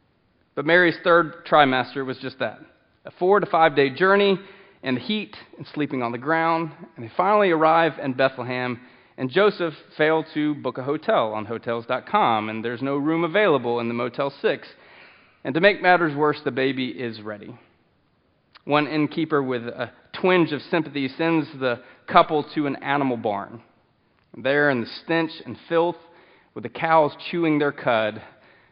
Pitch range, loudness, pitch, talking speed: 125-165 Hz, -22 LUFS, 145 Hz, 165 wpm